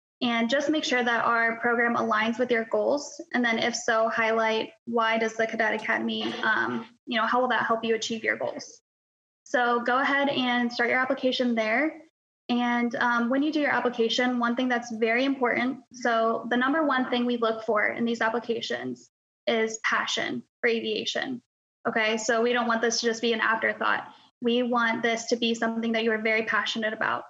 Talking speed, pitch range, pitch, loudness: 200 wpm, 225-250 Hz, 235 Hz, -26 LUFS